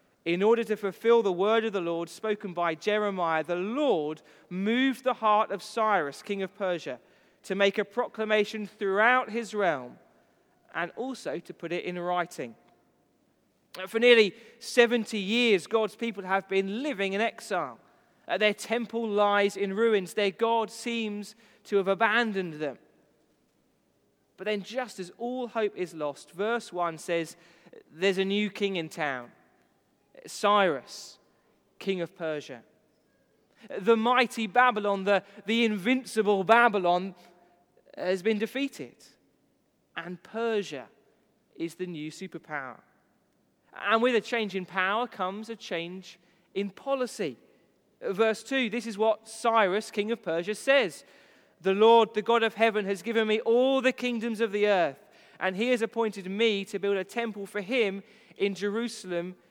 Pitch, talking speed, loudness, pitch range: 210 Hz, 145 wpm, -28 LUFS, 185-230 Hz